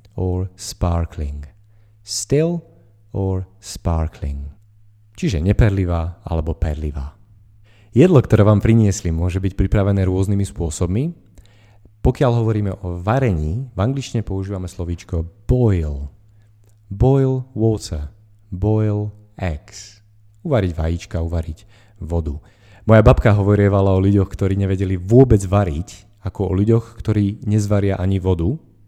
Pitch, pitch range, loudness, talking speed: 100 Hz, 90-105 Hz, -19 LUFS, 105 wpm